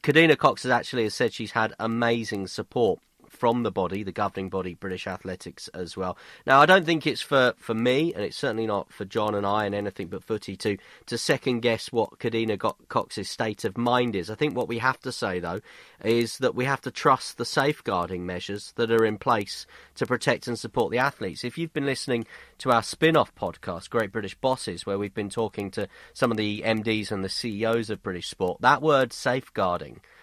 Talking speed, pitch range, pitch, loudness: 210 wpm, 100-125 Hz, 115 Hz, -26 LUFS